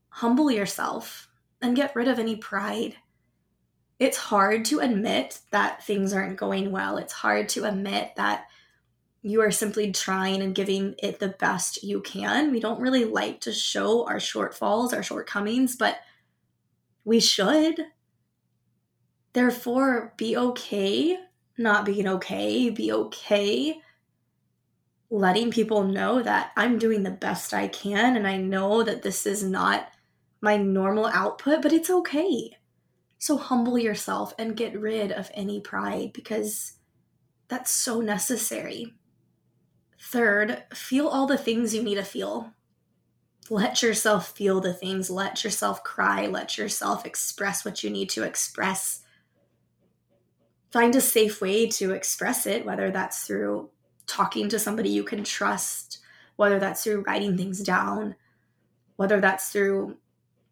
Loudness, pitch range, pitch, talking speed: -25 LUFS, 195-240 Hz, 210 Hz, 140 wpm